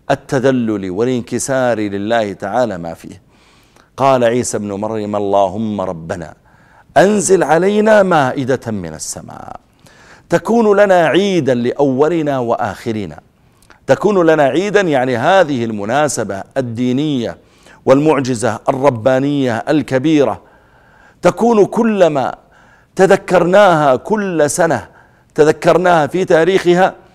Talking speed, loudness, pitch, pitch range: 90 wpm, -14 LUFS, 135 Hz, 115-175 Hz